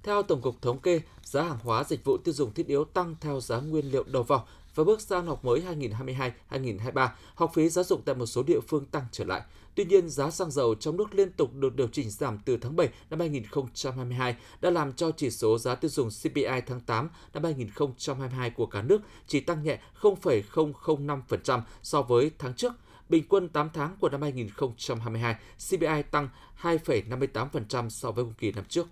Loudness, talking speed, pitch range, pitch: -29 LUFS, 200 wpm, 125-165 Hz, 145 Hz